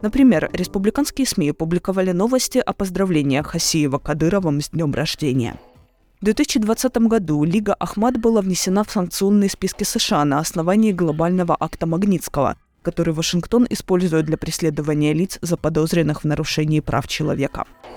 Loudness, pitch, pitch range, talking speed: -19 LUFS, 175 Hz, 155-210 Hz, 130 wpm